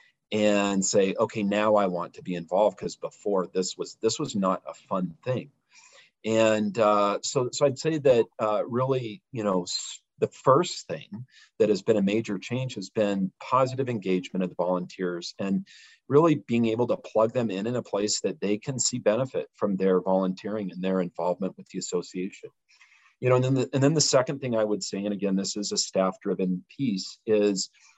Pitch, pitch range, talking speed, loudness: 105 Hz, 95-120 Hz, 200 wpm, -26 LUFS